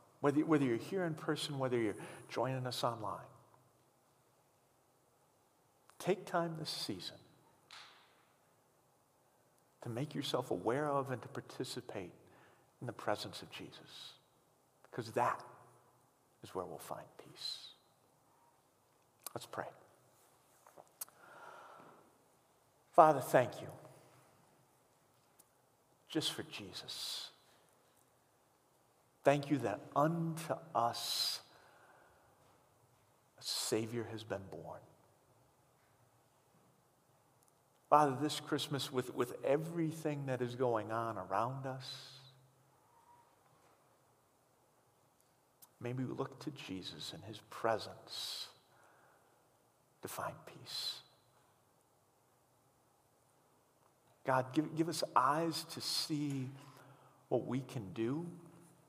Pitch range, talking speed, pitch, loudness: 125-155 Hz, 90 wpm, 135 Hz, -38 LUFS